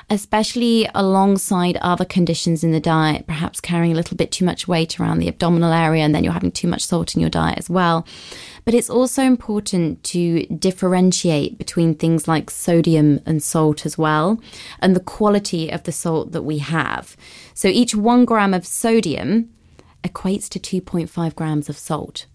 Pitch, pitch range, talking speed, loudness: 170 Hz, 160-195 Hz, 175 wpm, -18 LUFS